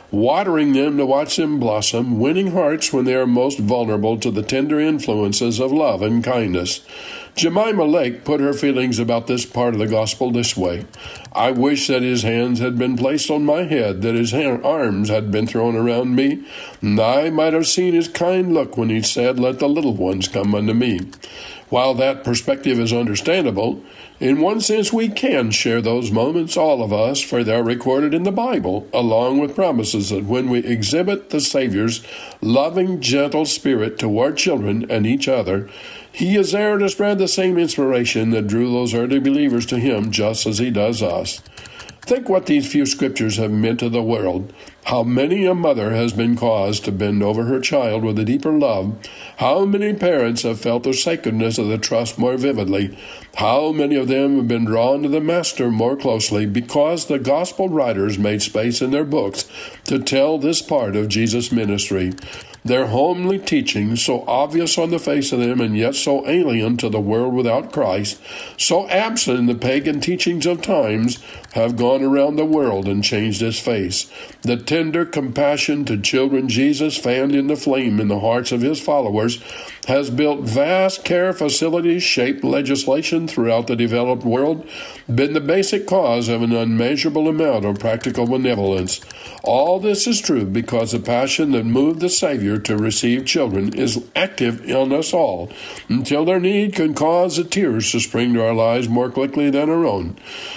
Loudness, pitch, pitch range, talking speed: -18 LUFS, 125 Hz, 115-155 Hz, 185 wpm